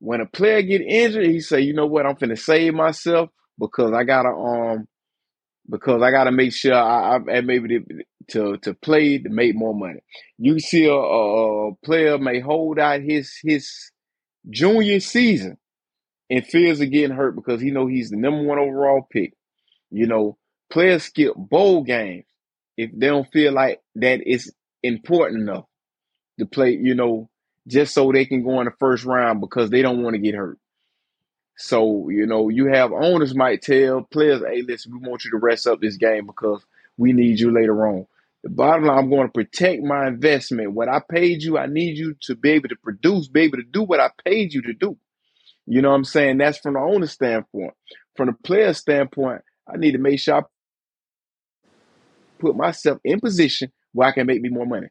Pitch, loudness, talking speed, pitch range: 135 Hz, -19 LUFS, 200 wpm, 120-150 Hz